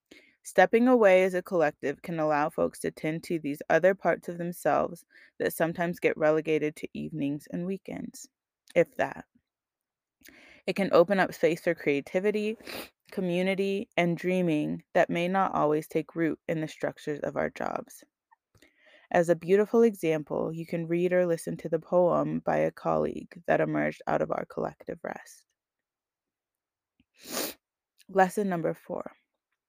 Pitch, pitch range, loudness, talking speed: 175 Hz, 155-195 Hz, -28 LUFS, 150 wpm